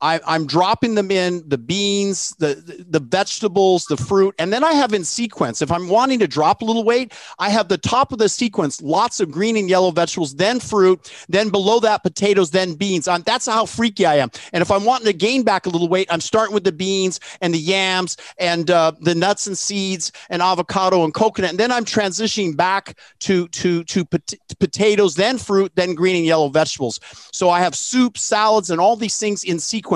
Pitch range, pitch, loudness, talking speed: 175-215 Hz, 190 Hz, -18 LUFS, 220 wpm